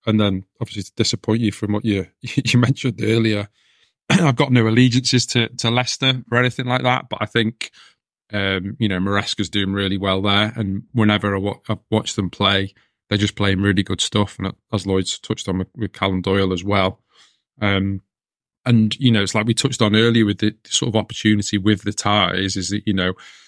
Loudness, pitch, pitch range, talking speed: -19 LUFS, 105 Hz, 100-115 Hz, 210 wpm